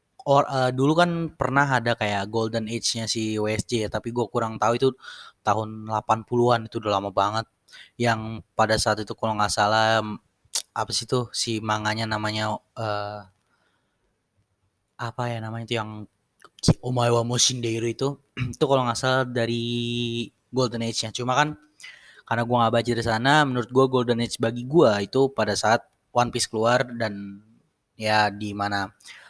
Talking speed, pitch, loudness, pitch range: 160 wpm, 115 Hz, -24 LUFS, 110-125 Hz